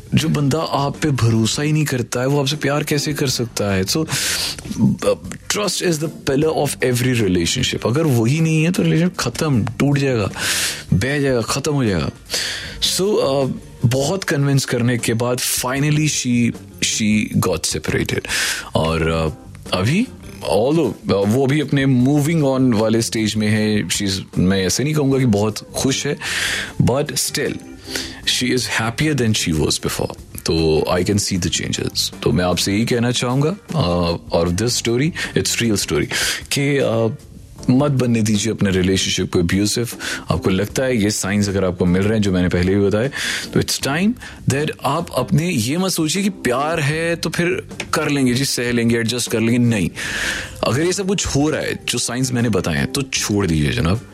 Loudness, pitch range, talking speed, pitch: -18 LUFS, 100-145 Hz, 180 wpm, 120 Hz